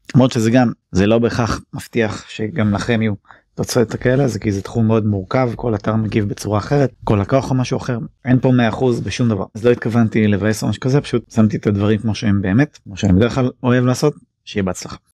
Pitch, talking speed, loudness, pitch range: 115 Hz, 215 wpm, -17 LUFS, 105-125 Hz